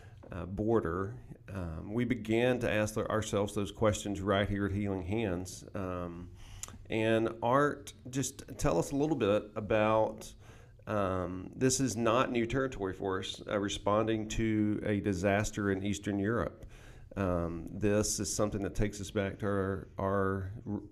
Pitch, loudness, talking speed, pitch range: 105 Hz, -33 LUFS, 150 wpm, 100-110 Hz